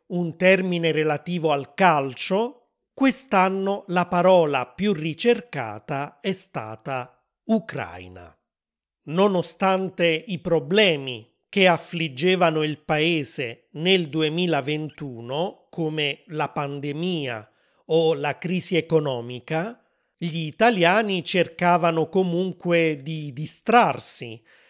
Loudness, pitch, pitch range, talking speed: -23 LUFS, 165 Hz, 145-185 Hz, 85 wpm